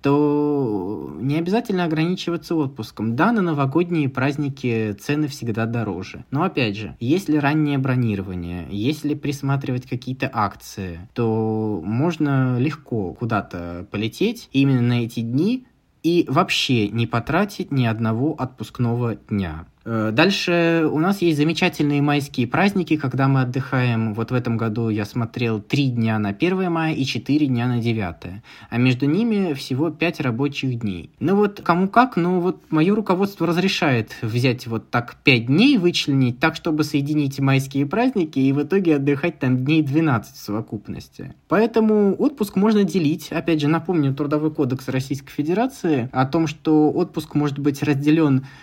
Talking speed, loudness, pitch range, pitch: 150 wpm, -21 LUFS, 120-165 Hz, 140 Hz